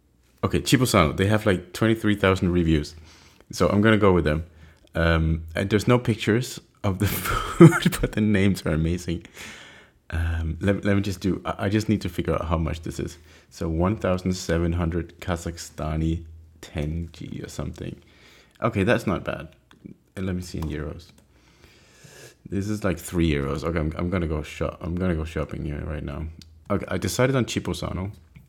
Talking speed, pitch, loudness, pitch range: 170 wpm, 85 Hz, -24 LUFS, 80-100 Hz